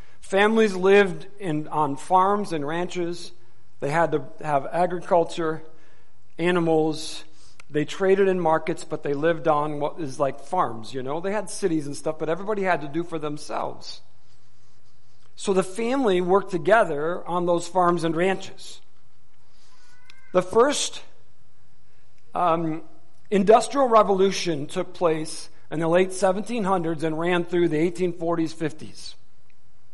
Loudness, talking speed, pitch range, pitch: -23 LUFS, 130 wpm, 145-185 Hz, 165 Hz